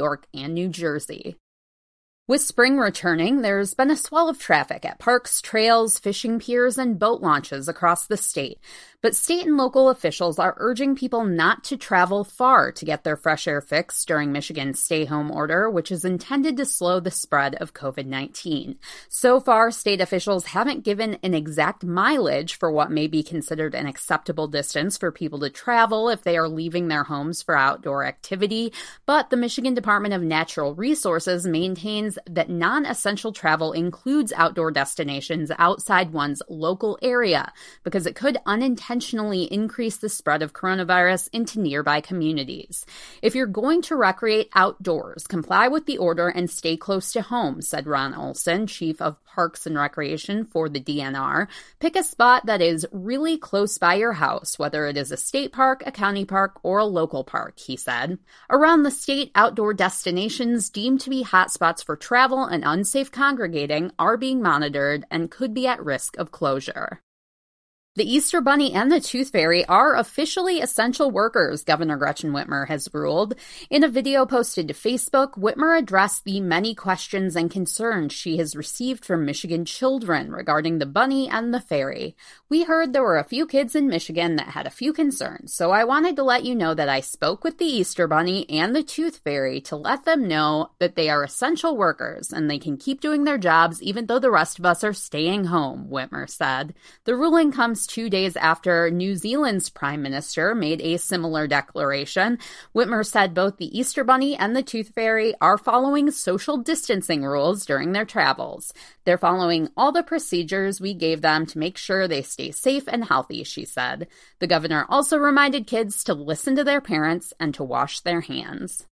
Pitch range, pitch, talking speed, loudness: 160-250 Hz, 195 Hz, 180 wpm, -22 LUFS